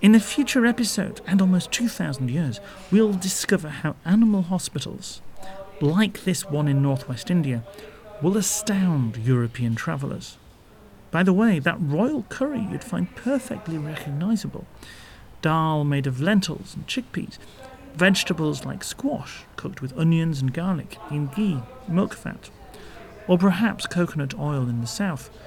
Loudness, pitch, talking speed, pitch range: -24 LUFS, 175 Hz, 135 wpm, 145-205 Hz